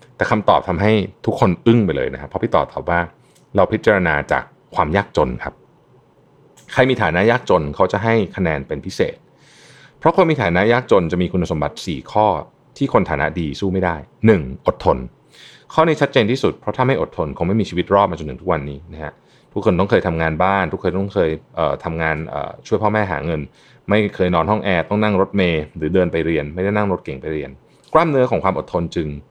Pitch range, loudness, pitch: 80-100 Hz, -18 LUFS, 90 Hz